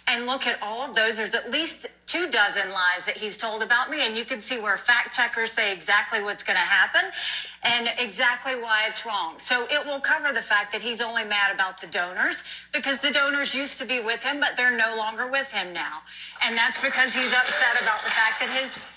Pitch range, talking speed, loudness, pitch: 215-260 Hz, 230 wpm, -23 LUFS, 240 Hz